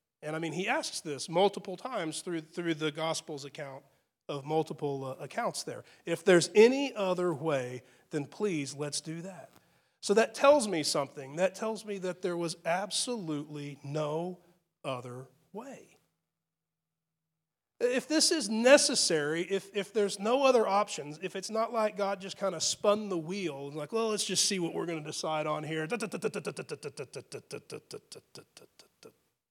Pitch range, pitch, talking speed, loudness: 155-210 Hz, 175 Hz, 155 wpm, -31 LUFS